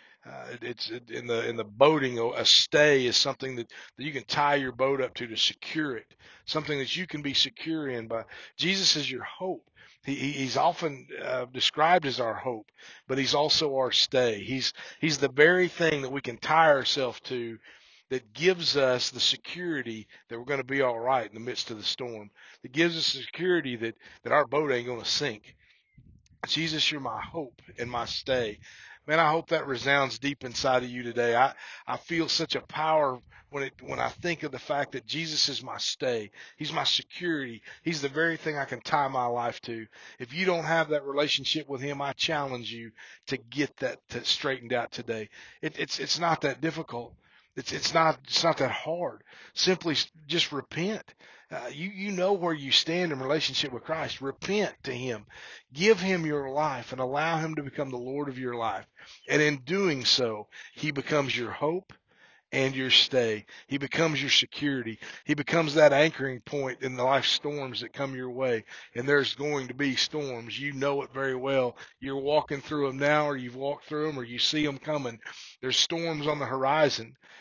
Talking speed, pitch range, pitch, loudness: 200 wpm, 125-155 Hz, 140 Hz, -27 LUFS